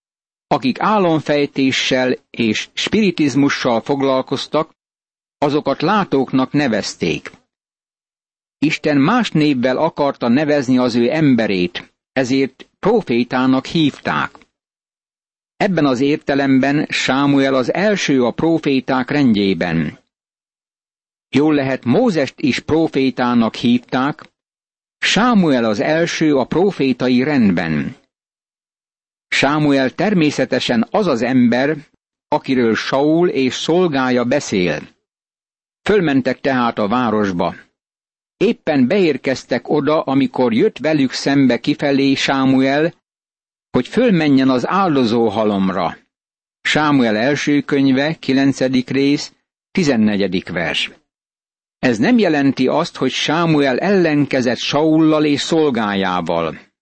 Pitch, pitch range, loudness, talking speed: 135 Hz, 125-155 Hz, -16 LUFS, 90 wpm